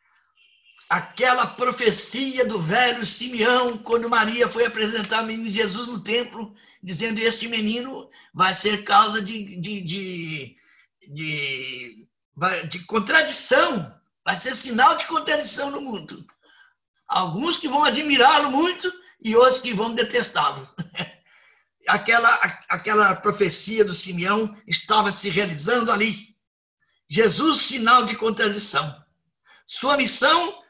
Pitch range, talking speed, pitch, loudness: 195-250 Hz, 115 wpm, 225 Hz, -21 LUFS